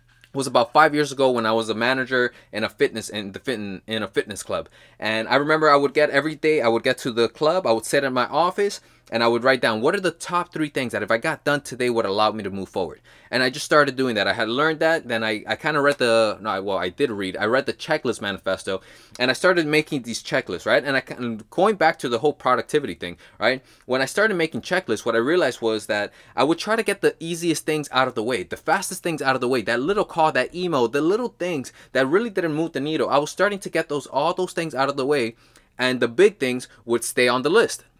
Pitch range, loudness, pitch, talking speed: 115-155 Hz, -22 LUFS, 135 Hz, 275 wpm